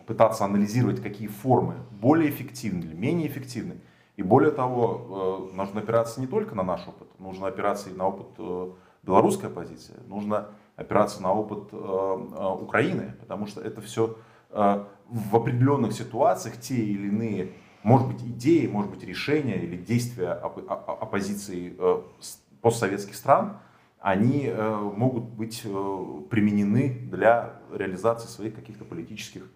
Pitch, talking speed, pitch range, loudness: 110 Hz, 125 wpm, 100-115 Hz, -26 LUFS